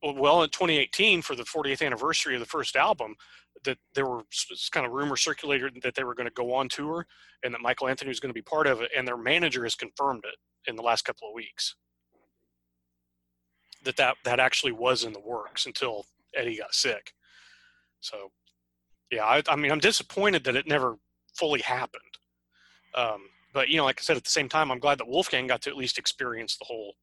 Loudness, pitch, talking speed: -27 LUFS, 125 Hz, 210 wpm